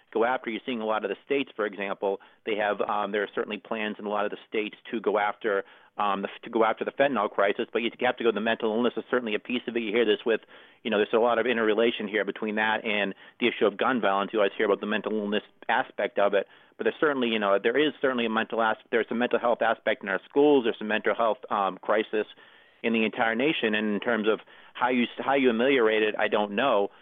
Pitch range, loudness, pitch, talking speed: 105-125 Hz, -26 LUFS, 115 Hz, 265 wpm